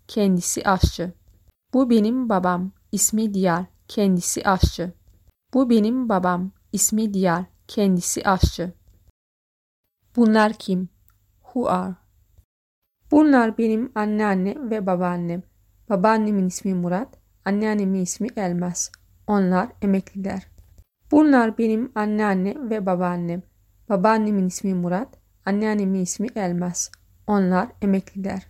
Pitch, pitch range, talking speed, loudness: 195 Hz, 180-215 Hz, 95 wpm, -22 LUFS